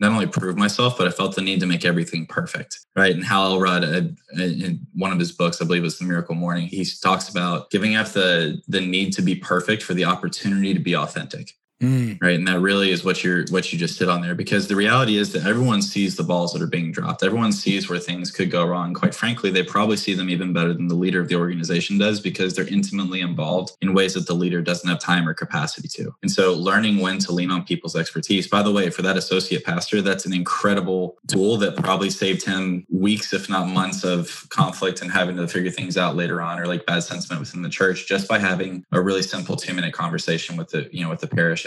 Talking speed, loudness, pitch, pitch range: 245 wpm, -21 LUFS, 95 Hz, 90-100 Hz